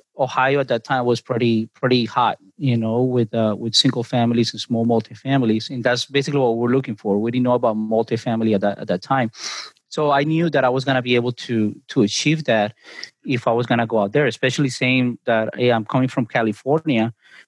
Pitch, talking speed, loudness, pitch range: 120 Hz, 225 wpm, -20 LUFS, 115-130 Hz